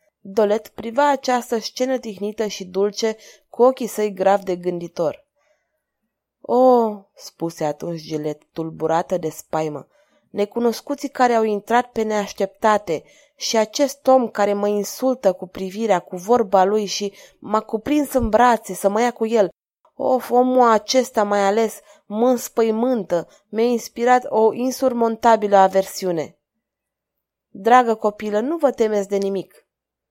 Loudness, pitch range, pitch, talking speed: -20 LUFS, 195-245 Hz, 220 Hz, 130 wpm